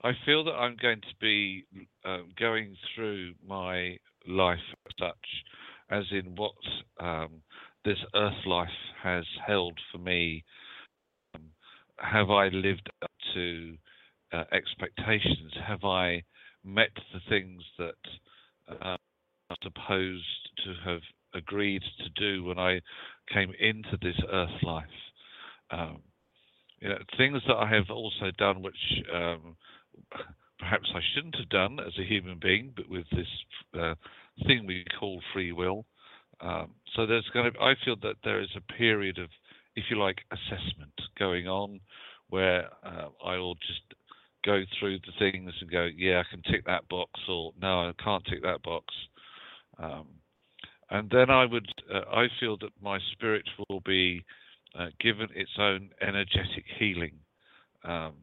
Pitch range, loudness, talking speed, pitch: 90-105 Hz, -30 LUFS, 150 wpm, 95 Hz